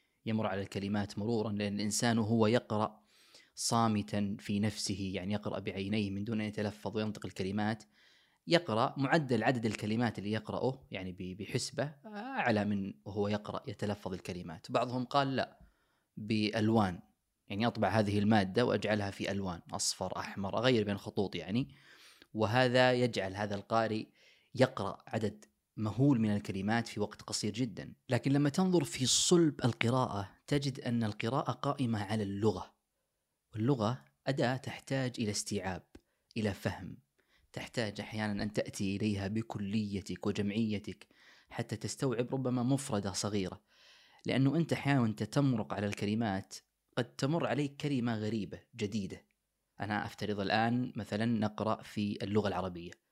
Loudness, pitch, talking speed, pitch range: -34 LUFS, 110 Hz, 130 wpm, 105-125 Hz